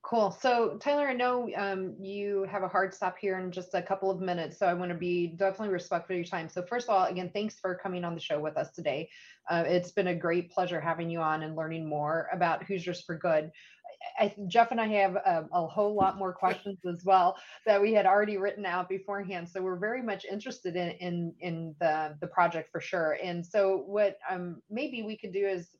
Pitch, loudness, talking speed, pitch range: 185 Hz, -31 LUFS, 235 wpm, 175-200 Hz